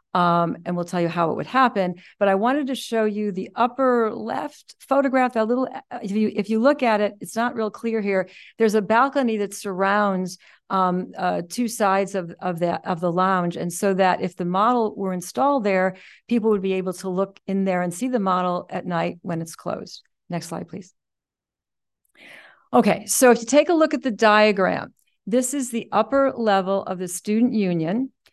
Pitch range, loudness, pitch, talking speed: 185-235 Hz, -22 LUFS, 205 Hz, 205 wpm